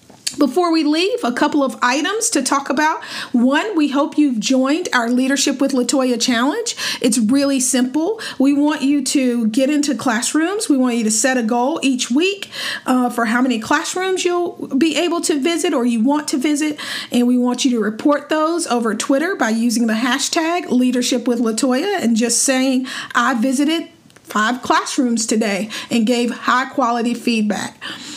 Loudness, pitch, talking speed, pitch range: -17 LUFS, 270 Hz, 175 wpm, 245-305 Hz